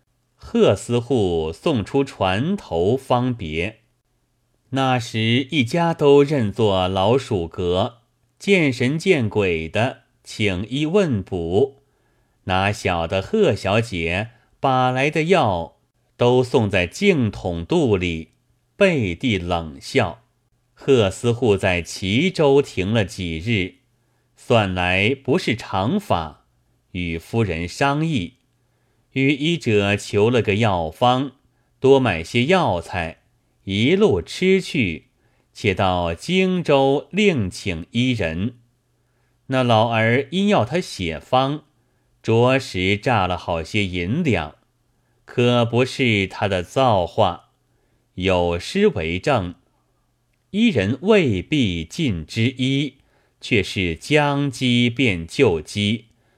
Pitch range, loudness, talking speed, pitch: 100-135 Hz, -20 LUFS, 145 characters per minute, 120 Hz